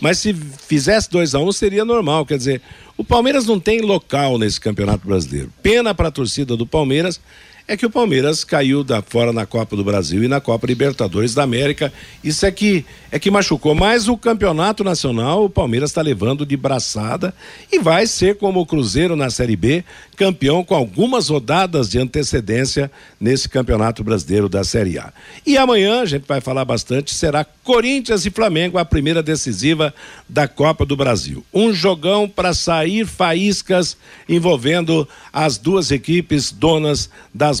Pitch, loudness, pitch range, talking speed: 150 Hz, -17 LUFS, 130-190 Hz, 170 wpm